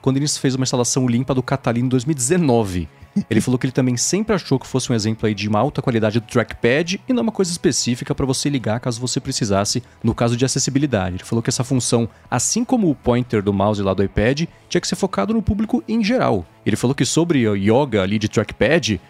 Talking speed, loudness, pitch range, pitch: 230 wpm, -19 LUFS, 110-145 Hz, 125 Hz